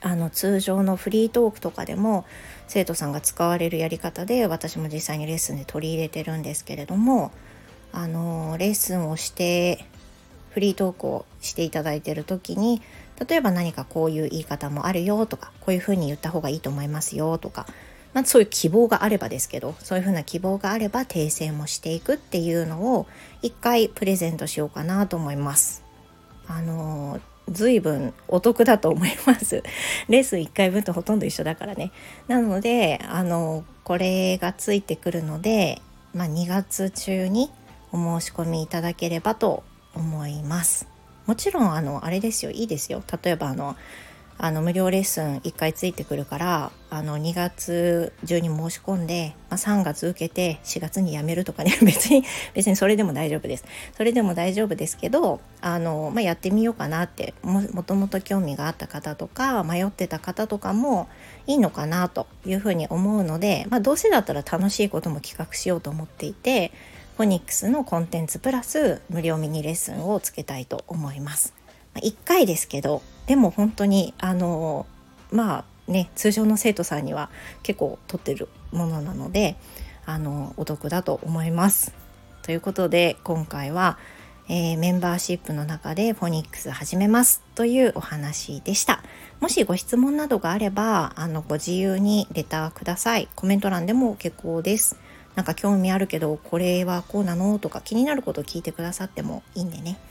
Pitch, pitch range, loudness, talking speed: 175 Hz, 160-205 Hz, -24 LUFS, 355 characters per minute